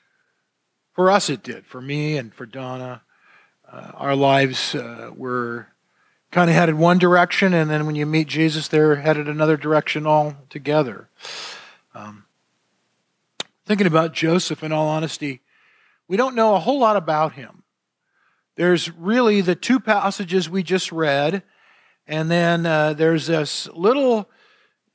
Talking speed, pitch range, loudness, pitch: 145 wpm, 150-195 Hz, -19 LUFS, 160 Hz